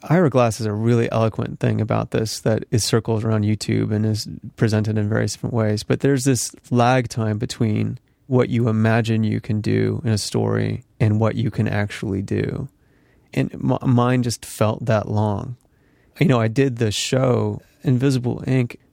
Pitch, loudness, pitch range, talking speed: 115 Hz, -21 LUFS, 110-125 Hz, 180 wpm